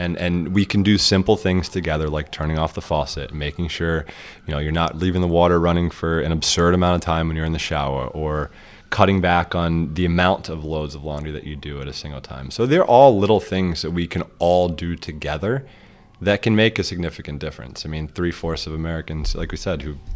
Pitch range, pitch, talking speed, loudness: 75-90 Hz, 85 Hz, 230 wpm, -20 LUFS